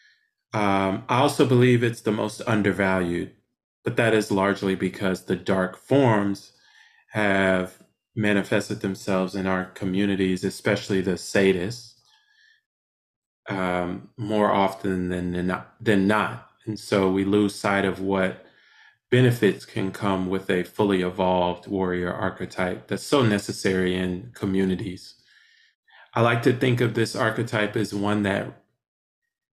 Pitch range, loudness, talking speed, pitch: 95-115 Hz, -24 LUFS, 125 wpm, 100 Hz